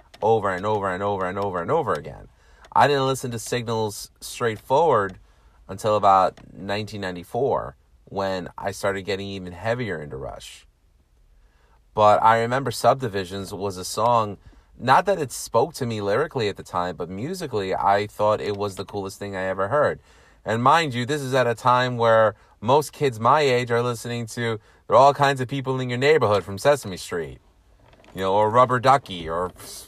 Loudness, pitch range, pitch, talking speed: -22 LUFS, 95-120 Hz, 105 Hz, 180 wpm